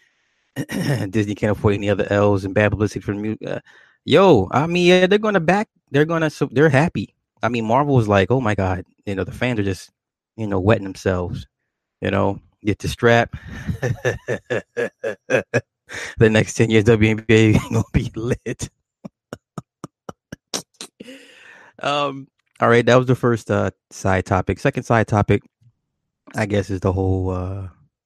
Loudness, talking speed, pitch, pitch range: -19 LUFS, 160 wpm, 110 Hz, 100-130 Hz